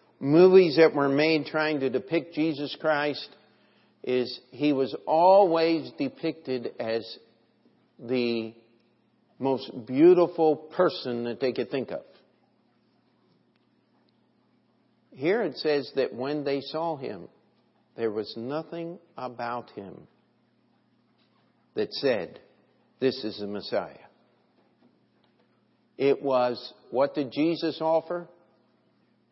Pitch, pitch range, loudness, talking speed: 145 Hz, 125-160 Hz, -26 LUFS, 100 wpm